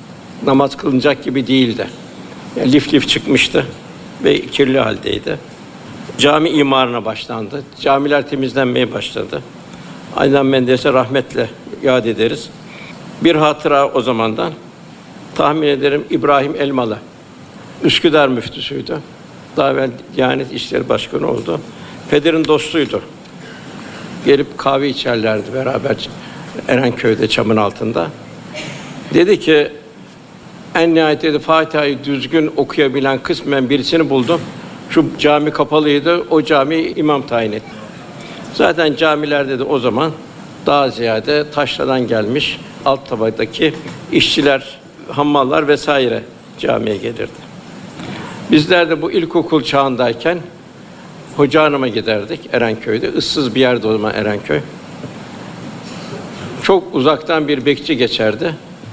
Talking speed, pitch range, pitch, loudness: 105 wpm, 130-155 Hz, 140 Hz, -15 LUFS